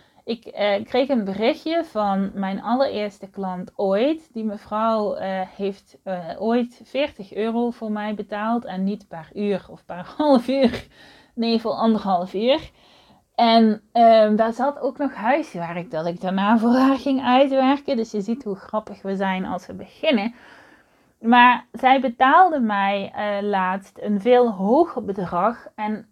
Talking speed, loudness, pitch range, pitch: 155 wpm, -21 LUFS, 195-250 Hz, 220 Hz